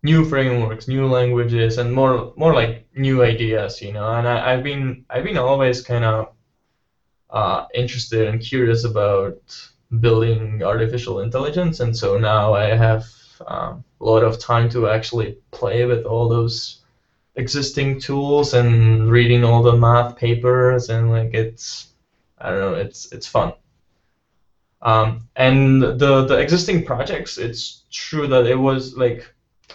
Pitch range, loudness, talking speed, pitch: 115-130 Hz, -18 LUFS, 145 wpm, 120 Hz